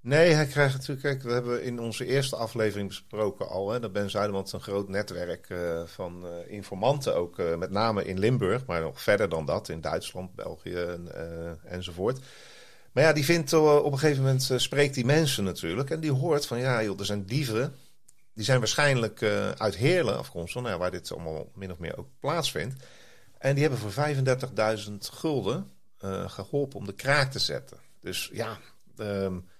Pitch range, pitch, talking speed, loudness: 95-135 Hz, 110 Hz, 195 wpm, -28 LUFS